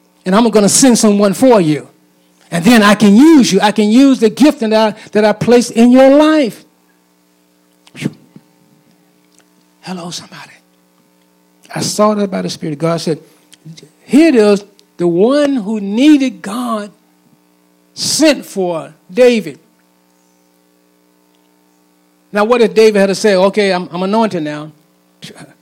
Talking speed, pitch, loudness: 140 wpm, 175 Hz, -11 LUFS